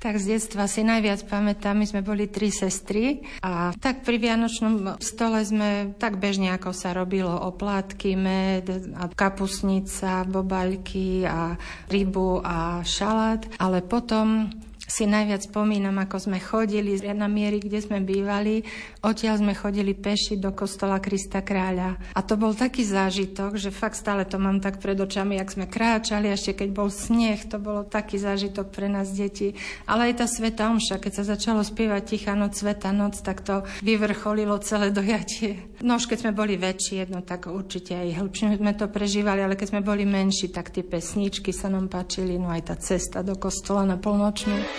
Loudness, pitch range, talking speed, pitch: -25 LUFS, 190-210 Hz, 175 wpm, 200 Hz